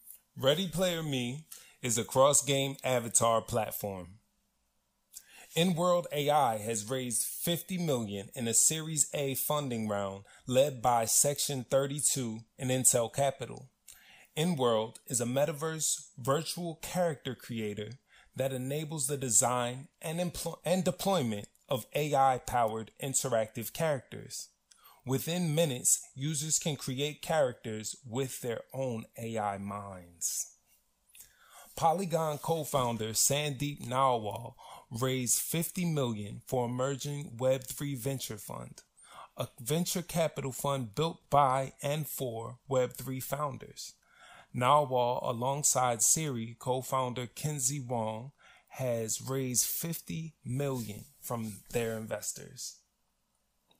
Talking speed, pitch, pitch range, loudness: 105 wpm, 130 Hz, 120-150 Hz, -31 LUFS